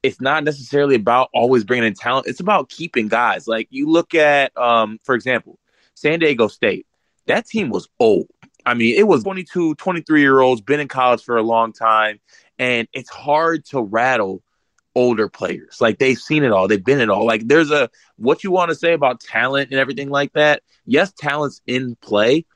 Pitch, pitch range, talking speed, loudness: 130 Hz, 115-150 Hz, 200 wpm, -17 LUFS